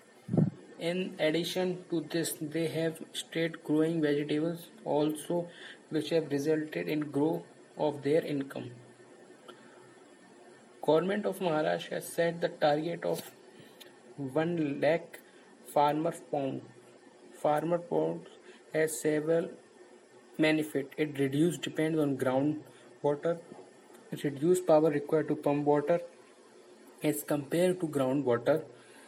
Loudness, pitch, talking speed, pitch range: -31 LUFS, 155 Hz, 105 wpm, 145-165 Hz